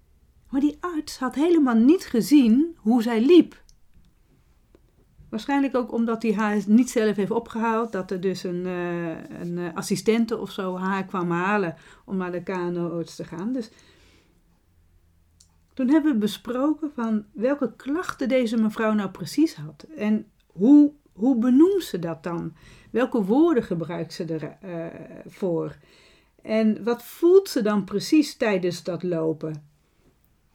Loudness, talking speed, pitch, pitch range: -23 LUFS, 140 wpm, 210 Hz, 170-250 Hz